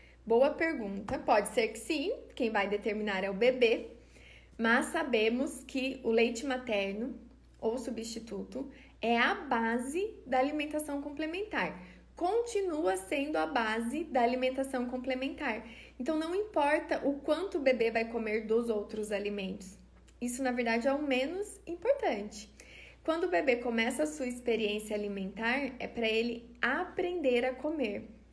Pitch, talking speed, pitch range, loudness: 255 Hz, 140 wpm, 230-305 Hz, -32 LUFS